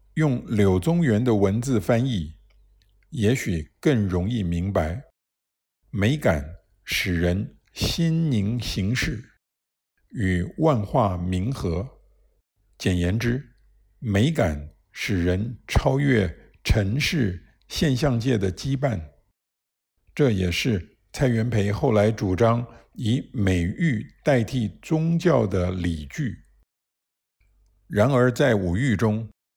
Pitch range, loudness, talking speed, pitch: 90-120 Hz, -24 LUFS, 145 characters per minute, 105 Hz